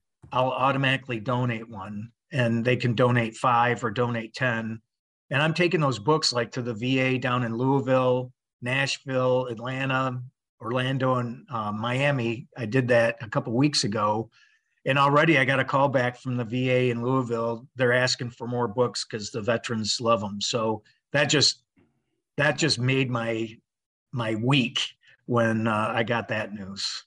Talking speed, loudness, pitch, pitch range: 165 wpm, -25 LUFS, 125 Hz, 115-130 Hz